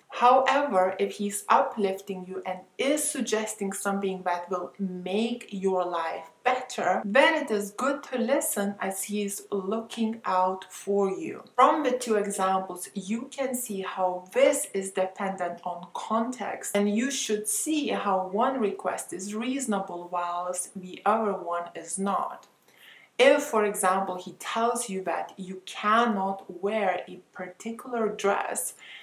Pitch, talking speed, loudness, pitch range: 200 Hz, 140 wpm, -27 LUFS, 185-235 Hz